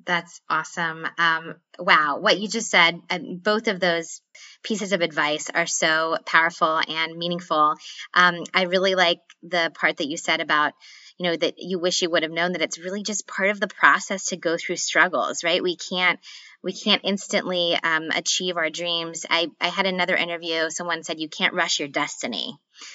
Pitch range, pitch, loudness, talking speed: 165-185 Hz, 170 Hz, -22 LUFS, 190 wpm